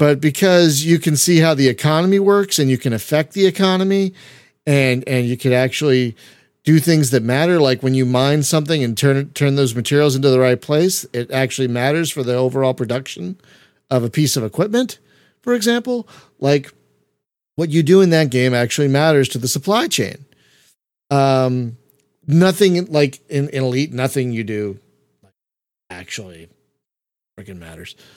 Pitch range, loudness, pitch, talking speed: 125-160 Hz, -16 LUFS, 140 Hz, 165 wpm